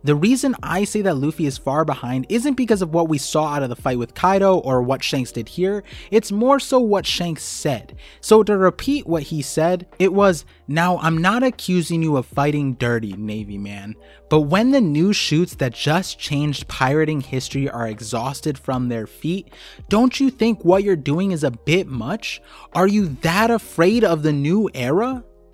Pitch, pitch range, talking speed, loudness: 165 Hz, 135-195 Hz, 195 wpm, -19 LUFS